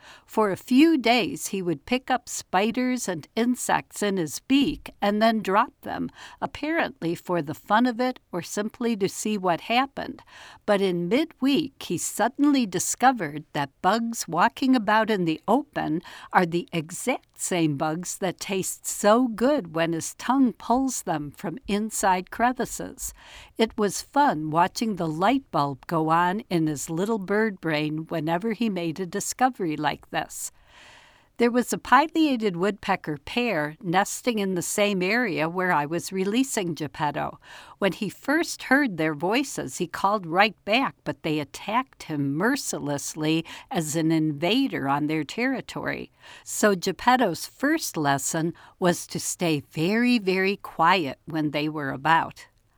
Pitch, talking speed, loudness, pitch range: 195 Hz, 150 wpm, -25 LUFS, 165-240 Hz